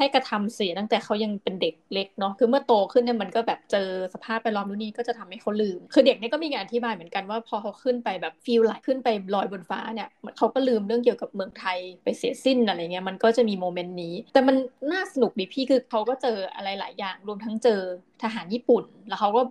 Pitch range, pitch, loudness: 195-245 Hz, 225 Hz, -26 LUFS